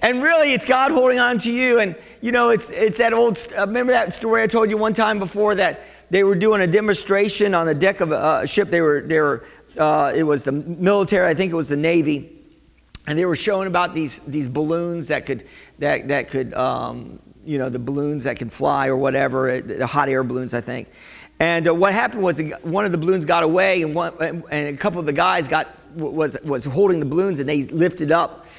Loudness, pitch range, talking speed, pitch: -19 LUFS, 150-205 Hz, 235 wpm, 170 Hz